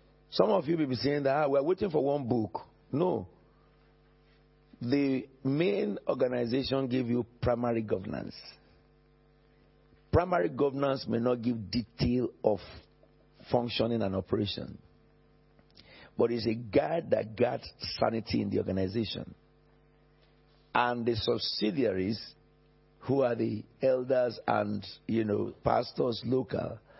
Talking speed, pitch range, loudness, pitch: 120 wpm, 115-135 Hz, -31 LUFS, 120 Hz